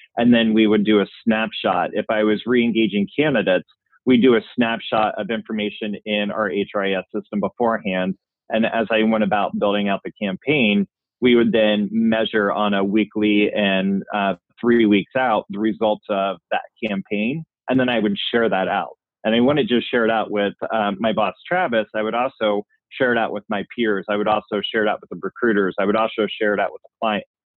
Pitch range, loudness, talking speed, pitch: 100-110 Hz, -20 LUFS, 210 wpm, 105 Hz